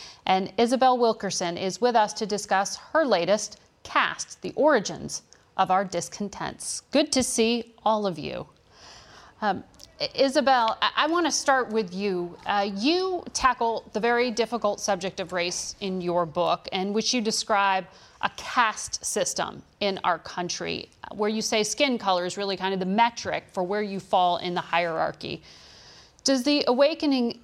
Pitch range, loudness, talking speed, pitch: 190-245 Hz, -25 LUFS, 160 wpm, 210 Hz